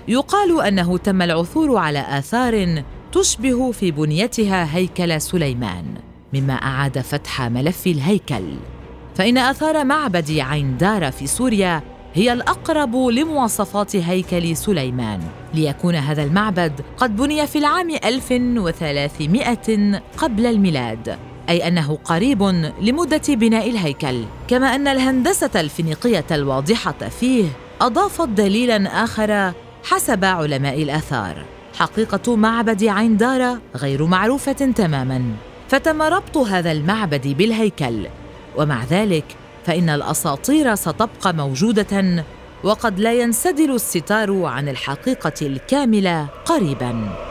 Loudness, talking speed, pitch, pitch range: -18 LUFS, 105 wpm, 185 Hz, 150-240 Hz